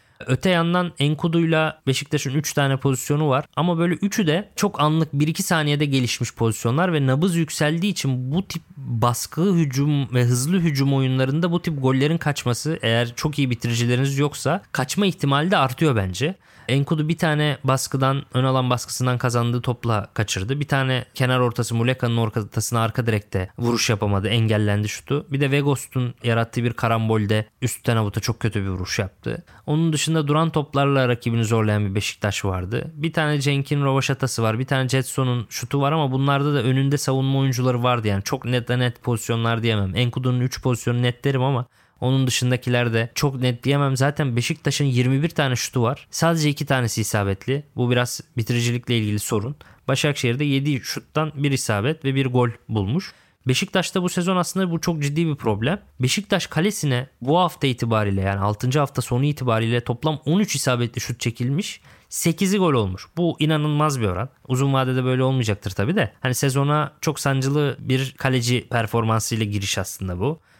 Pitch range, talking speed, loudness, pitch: 120-150 Hz, 165 wpm, -22 LUFS, 130 Hz